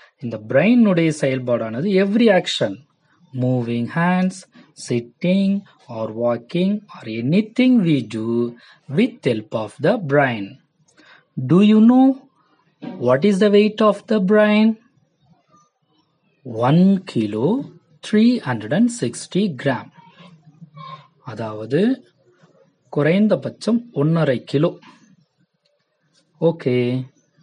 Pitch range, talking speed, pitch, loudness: 130-205 Hz, 95 wpm, 165 Hz, -18 LUFS